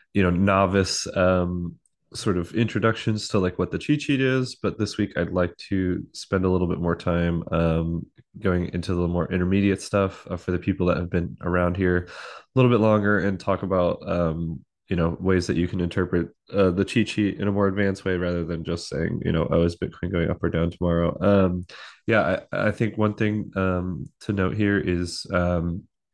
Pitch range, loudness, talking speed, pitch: 85-100 Hz, -24 LUFS, 215 wpm, 90 Hz